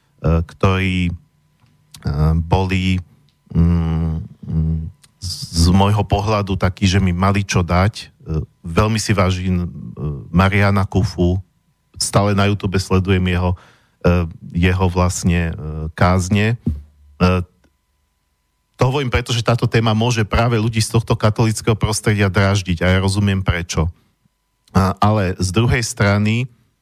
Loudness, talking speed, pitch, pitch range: -18 LUFS, 105 wpm, 95 Hz, 90-105 Hz